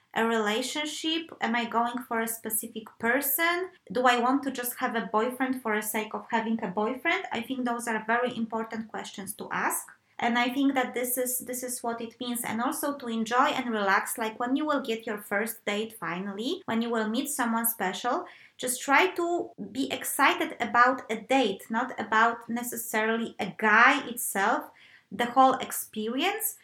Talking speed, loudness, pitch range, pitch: 185 wpm, -28 LUFS, 225-260 Hz, 240 Hz